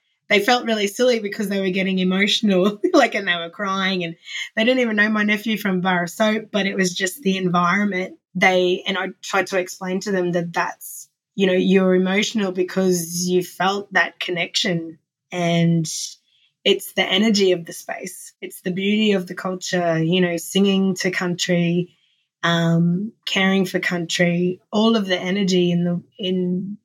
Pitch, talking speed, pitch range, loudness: 185 Hz, 175 wpm, 175-200 Hz, -20 LUFS